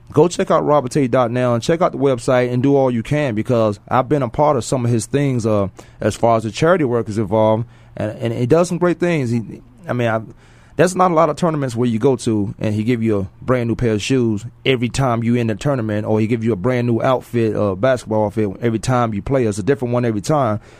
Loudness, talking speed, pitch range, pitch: -18 LUFS, 265 wpm, 110-135 Hz, 120 Hz